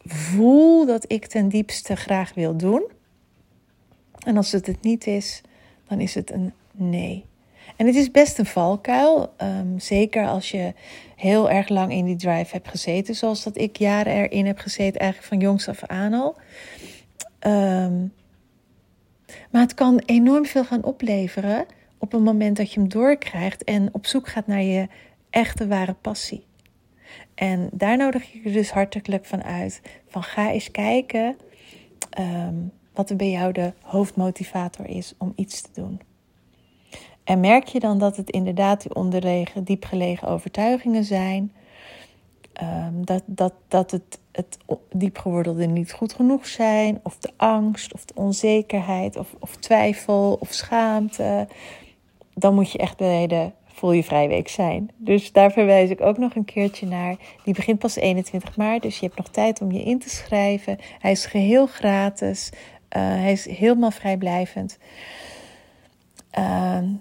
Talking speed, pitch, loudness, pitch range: 160 wpm, 200 Hz, -22 LUFS, 185-220 Hz